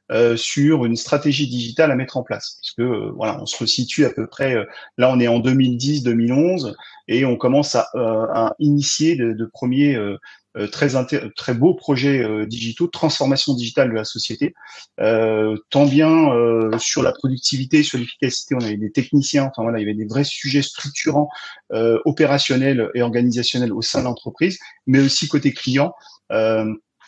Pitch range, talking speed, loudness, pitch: 115-145 Hz, 185 wpm, -19 LUFS, 130 Hz